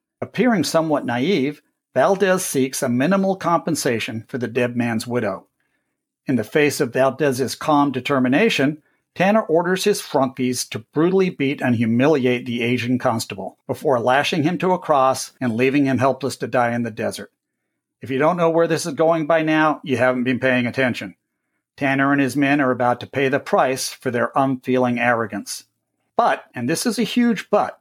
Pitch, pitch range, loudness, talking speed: 135 Hz, 125-160 Hz, -20 LUFS, 180 wpm